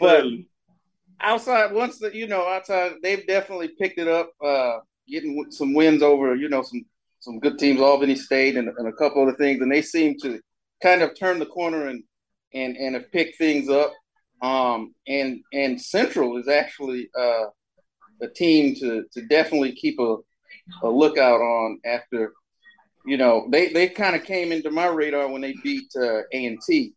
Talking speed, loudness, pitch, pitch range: 175 wpm, -22 LUFS, 150 Hz, 130-180 Hz